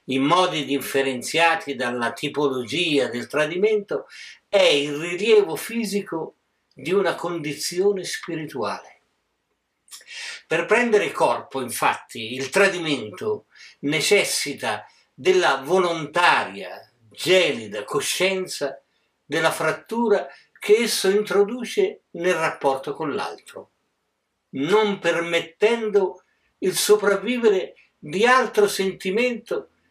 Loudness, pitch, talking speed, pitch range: -22 LUFS, 185 Hz, 85 wpm, 150-220 Hz